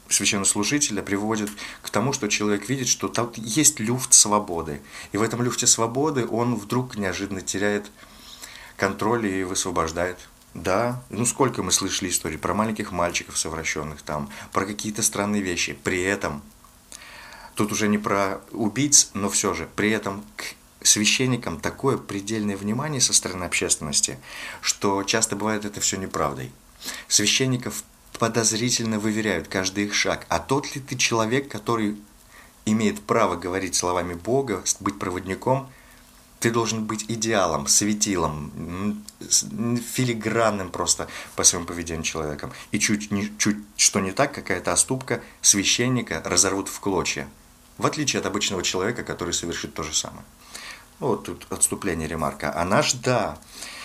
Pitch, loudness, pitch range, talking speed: 105 Hz, -23 LUFS, 90-115 Hz, 140 wpm